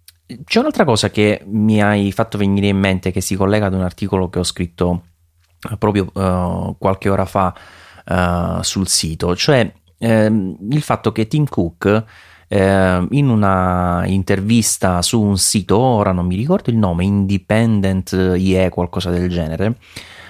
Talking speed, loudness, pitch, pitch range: 155 wpm, -16 LUFS, 95 Hz, 90-105 Hz